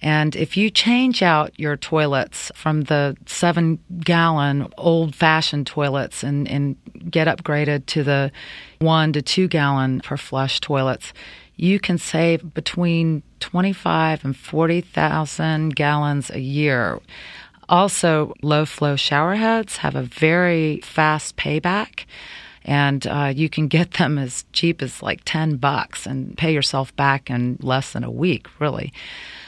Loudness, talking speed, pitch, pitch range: -20 LUFS, 135 wpm, 155 Hz, 140-165 Hz